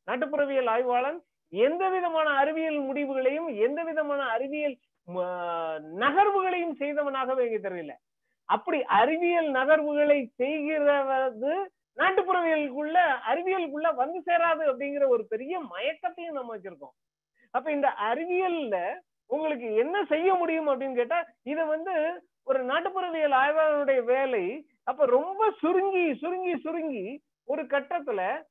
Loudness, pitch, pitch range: -27 LUFS, 300 Hz, 265-340 Hz